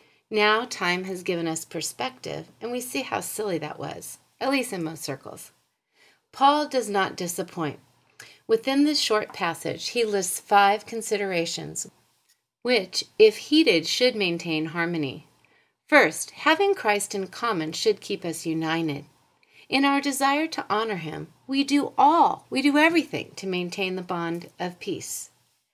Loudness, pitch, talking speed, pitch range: -24 LUFS, 195 Hz, 145 wpm, 170-255 Hz